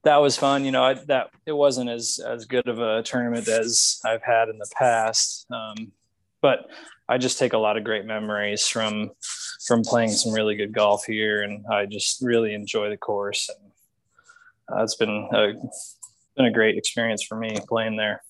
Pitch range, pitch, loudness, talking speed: 105-120 Hz, 110 Hz, -23 LUFS, 195 wpm